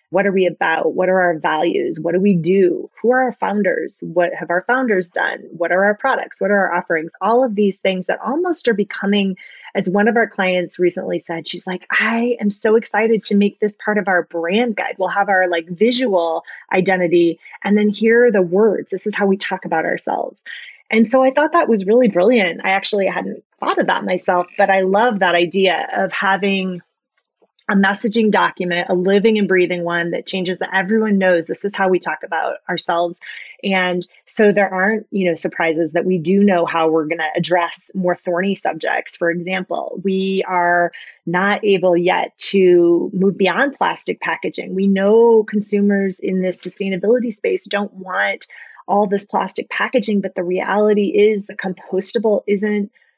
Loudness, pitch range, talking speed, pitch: -17 LUFS, 180-210 Hz, 190 wpm, 195 Hz